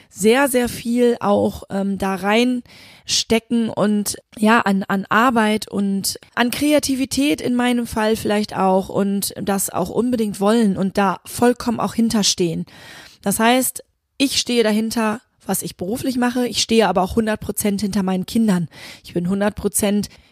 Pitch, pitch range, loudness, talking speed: 215 Hz, 195-235 Hz, -19 LUFS, 155 wpm